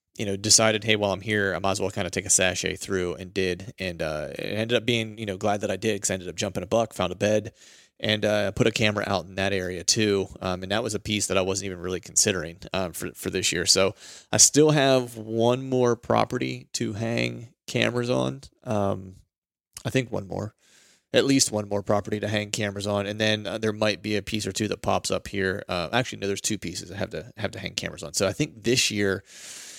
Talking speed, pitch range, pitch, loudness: 255 wpm, 95-110 Hz, 100 Hz, -25 LUFS